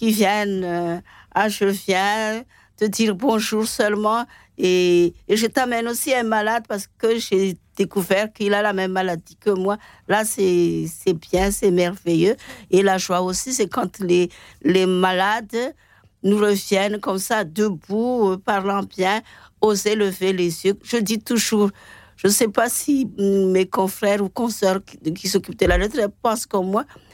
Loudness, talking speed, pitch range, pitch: -20 LUFS, 170 wpm, 185-220 Hz, 200 Hz